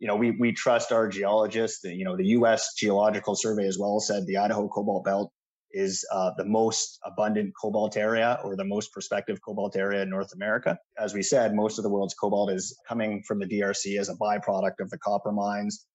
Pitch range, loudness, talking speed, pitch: 100-110 Hz, -27 LUFS, 215 wpm, 105 Hz